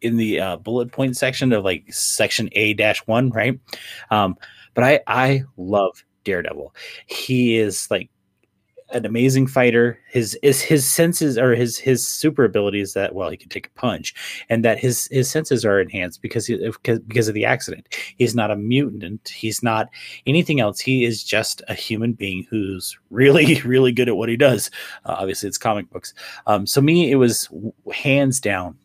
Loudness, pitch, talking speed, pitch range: -19 LUFS, 120 Hz, 180 wpm, 110-130 Hz